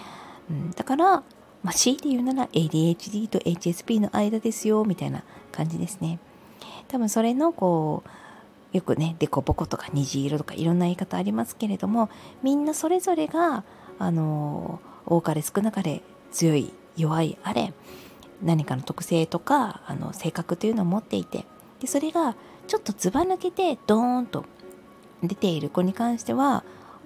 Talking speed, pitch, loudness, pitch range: 310 characters per minute, 195 Hz, -26 LUFS, 165-250 Hz